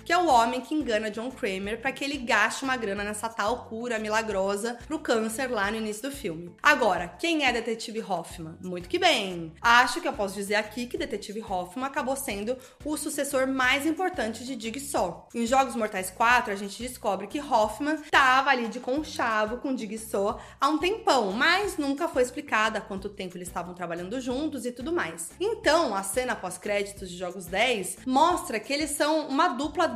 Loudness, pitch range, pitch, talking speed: -27 LUFS, 210-285 Hz, 245 Hz, 195 wpm